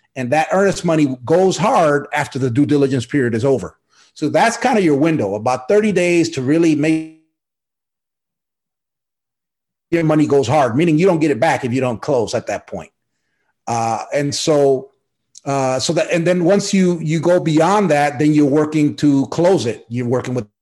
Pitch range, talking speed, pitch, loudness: 135-170 Hz, 190 wpm, 150 Hz, -16 LUFS